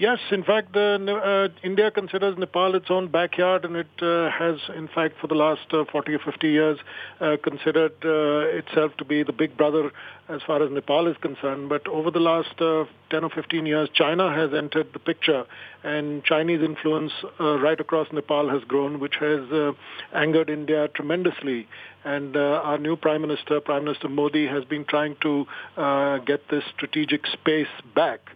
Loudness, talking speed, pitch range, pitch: -24 LUFS, 185 wpm, 150-165 Hz, 155 Hz